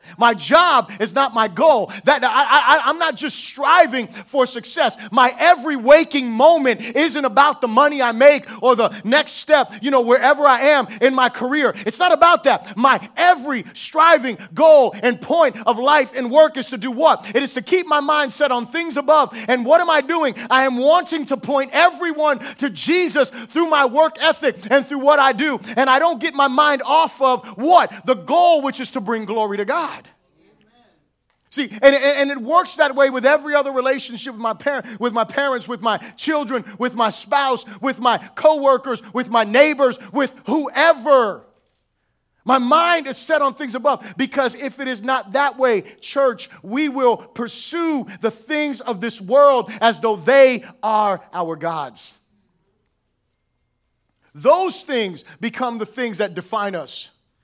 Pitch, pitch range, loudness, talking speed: 265 Hz, 235-295 Hz, -17 LUFS, 175 wpm